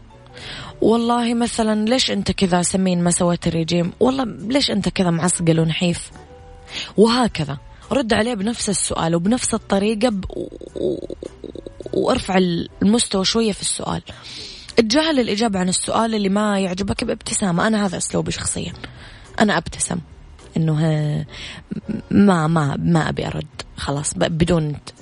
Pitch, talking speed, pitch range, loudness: 190 Hz, 120 wpm, 165-225 Hz, -19 LUFS